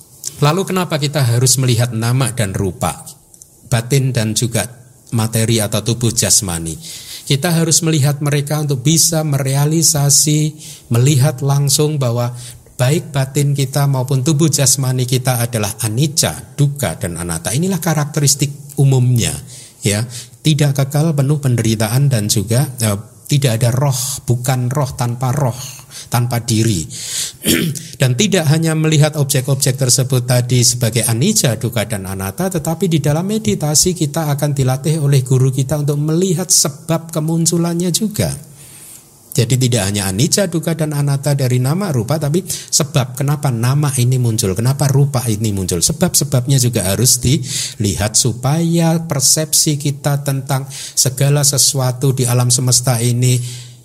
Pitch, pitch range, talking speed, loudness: 135 Hz, 120-150 Hz, 135 wpm, -15 LUFS